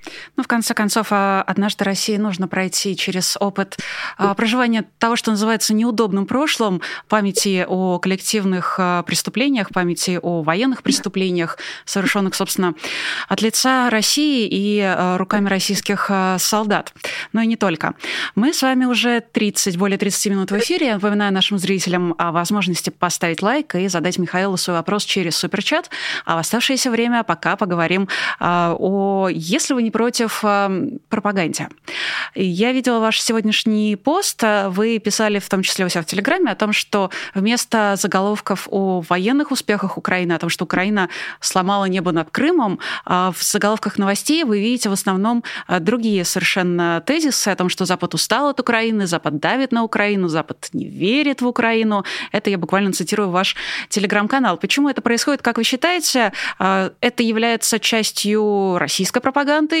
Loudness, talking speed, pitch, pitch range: -18 LUFS, 150 wpm, 205 Hz, 185-230 Hz